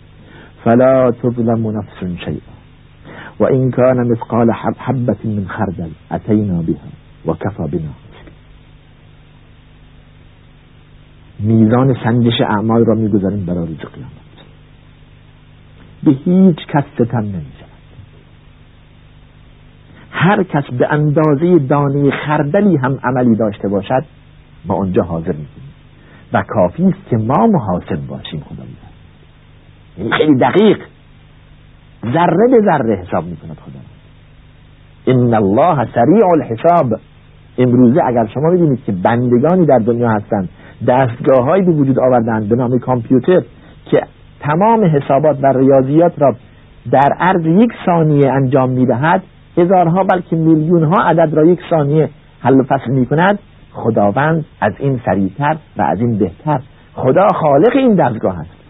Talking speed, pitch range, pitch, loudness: 120 wpm, 105-155 Hz, 125 Hz, -13 LUFS